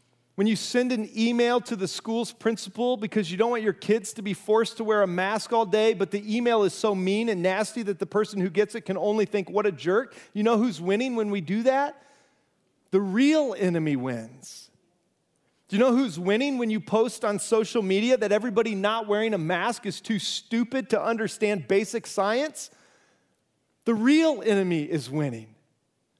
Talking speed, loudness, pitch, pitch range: 195 wpm, -25 LUFS, 215 Hz, 195-230 Hz